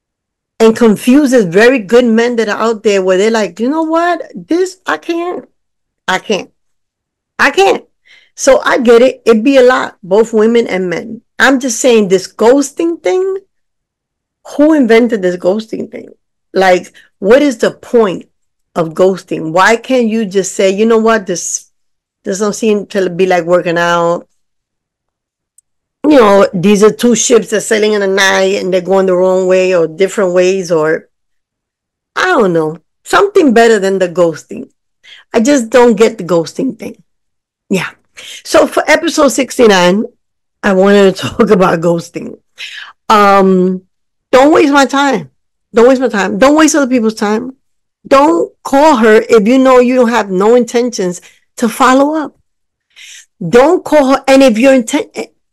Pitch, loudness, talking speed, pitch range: 225 Hz, -10 LUFS, 165 wpm, 190-265 Hz